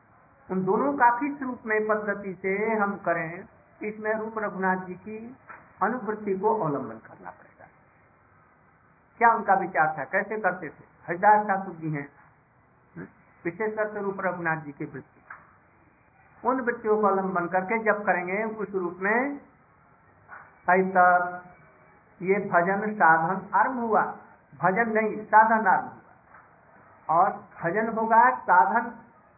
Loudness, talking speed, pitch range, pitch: -25 LUFS, 125 wpm, 180-220 Hz, 195 Hz